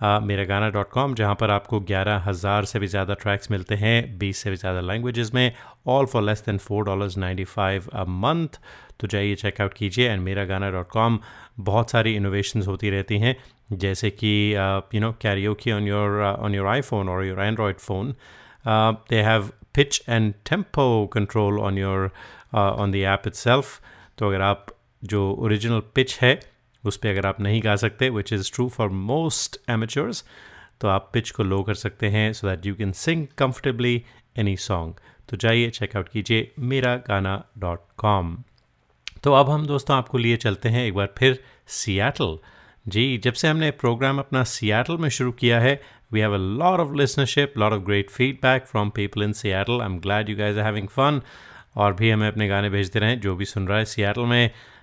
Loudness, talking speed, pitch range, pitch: -23 LUFS, 195 wpm, 100-125 Hz, 105 Hz